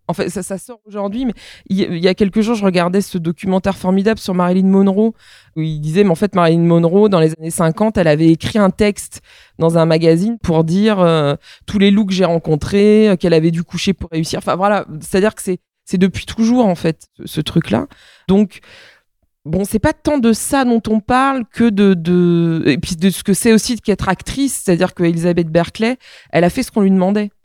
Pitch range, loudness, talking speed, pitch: 170-210 Hz, -15 LUFS, 215 wpm, 190 Hz